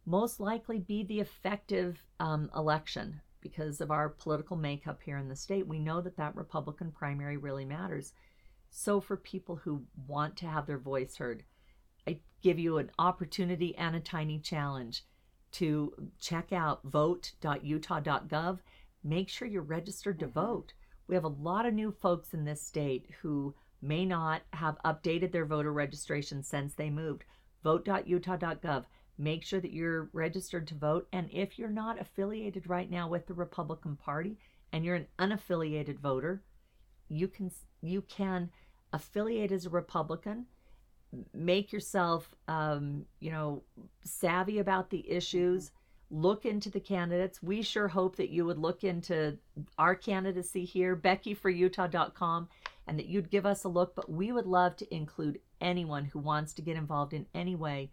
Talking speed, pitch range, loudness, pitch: 160 wpm, 150-185 Hz, -35 LUFS, 170 Hz